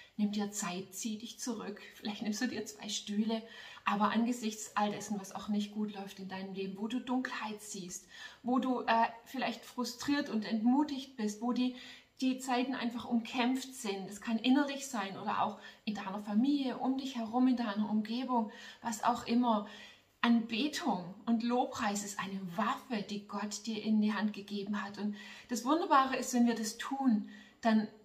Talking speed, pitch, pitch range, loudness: 180 wpm, 225 Hz, 210-250 Hz, -35 LUFS